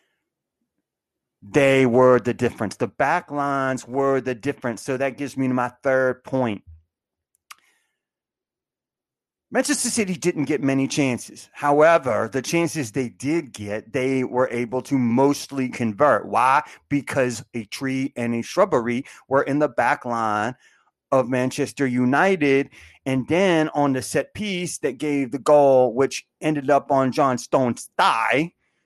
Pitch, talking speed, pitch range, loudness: 135 Hz, 140 wpm, 125-145 Hz, -21 LUFS